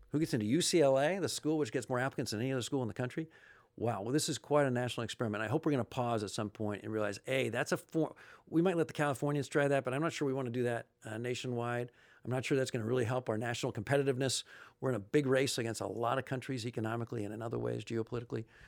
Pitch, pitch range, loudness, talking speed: 125 Hz, 115-140 Hz, -35 LUFS, 275 wpm